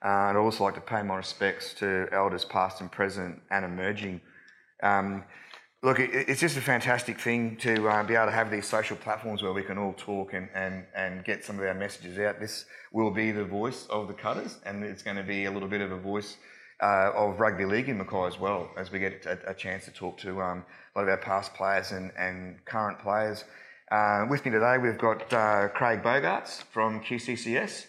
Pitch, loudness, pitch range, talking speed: 100 Hz, -29 LUFS, 95-110 Hz, 225 wpm